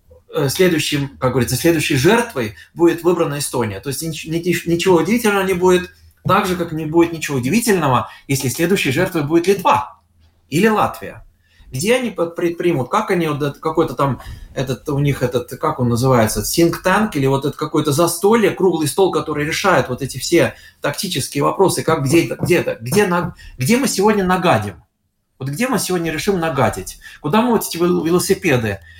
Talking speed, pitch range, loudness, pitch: 155 wpm, 130-180 Hz, -17 LUFS, 160 Hz